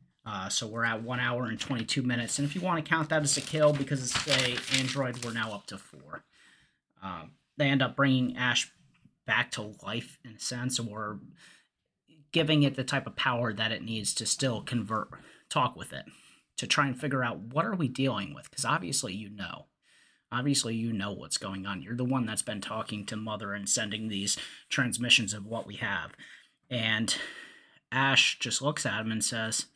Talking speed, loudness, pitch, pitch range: 200 wpm, -30 LUFS, 120 Hz, 110-135 Hz